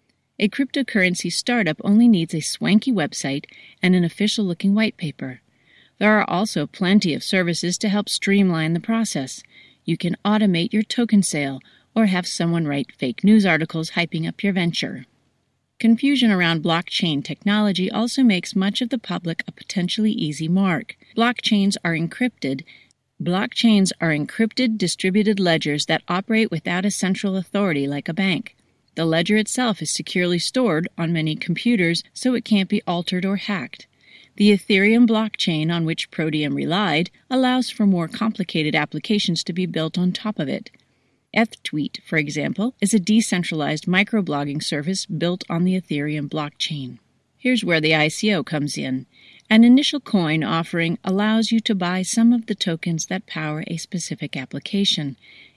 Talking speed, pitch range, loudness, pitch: 155 wpm, 160-215 Hz, -20 LUFS, 185 Hz